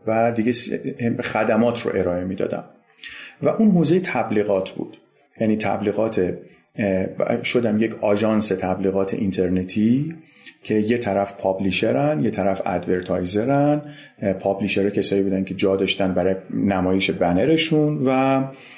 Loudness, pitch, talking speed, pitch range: -21 LUFS, 105 Hz, 110 wpm, 95-125 Hz